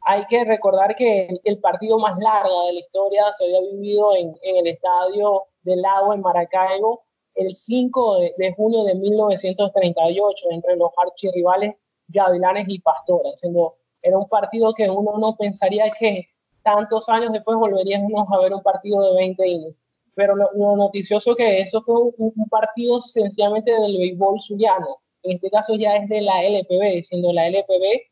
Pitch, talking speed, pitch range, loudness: 200 Hz, 170 wpm, 185-215 Hz, -19 LUFS